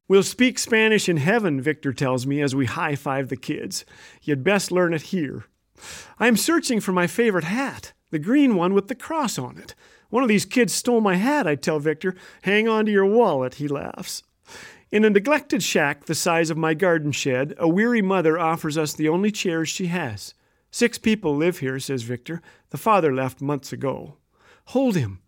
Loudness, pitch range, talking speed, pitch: -22 LUFS, 145-220 Hz, 200 wpm, 175 Hz